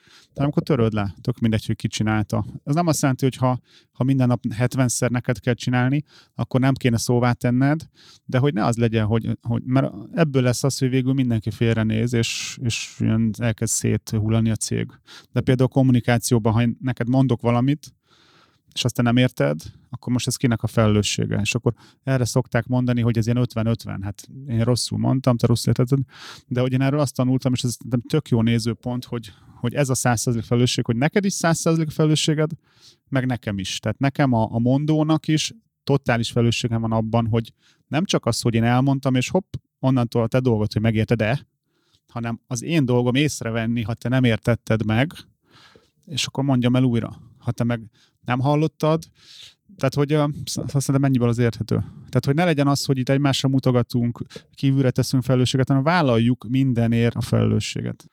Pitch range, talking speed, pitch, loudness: 115-135 Hz, 185 wpm, 125 Hz, -21 LUFS